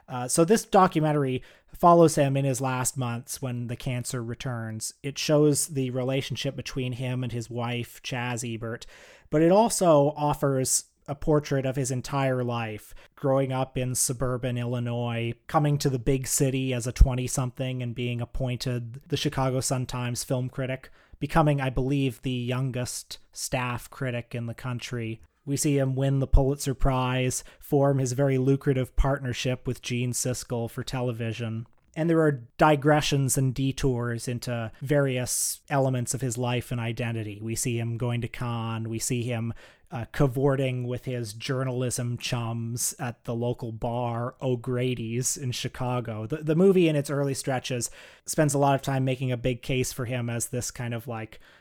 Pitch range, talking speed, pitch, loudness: 120-135 Hz, 165 wpm, 130 Hz, -27 LUFS